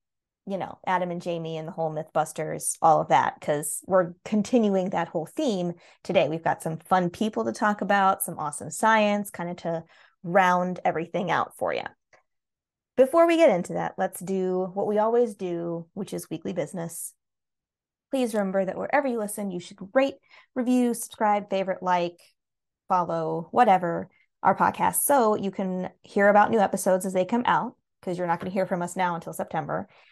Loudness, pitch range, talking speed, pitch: -25 LUFS, 170-210 Hz, 185 wpm, 190 Hz